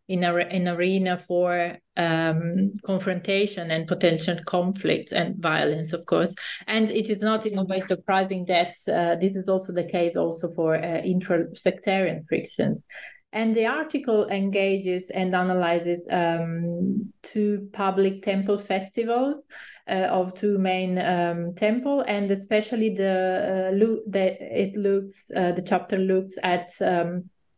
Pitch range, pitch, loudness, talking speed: 175-200 Hz, 185 Hz, -25 LUFS, 145 wpm